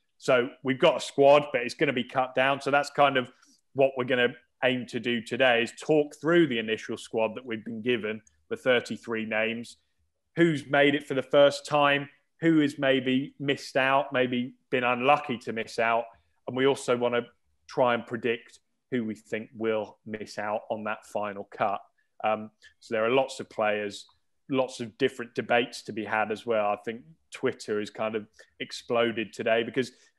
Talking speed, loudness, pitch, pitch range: 195 wpm, -27 LUFS, 125 Hz, 110-140 Hz